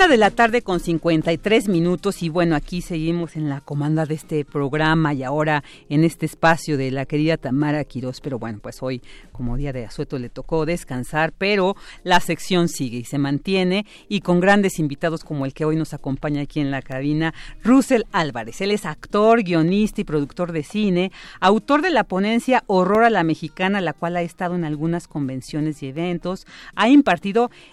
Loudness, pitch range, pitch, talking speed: -21 LUFS, 145-190 Hz, 165 Hz, 190 wpm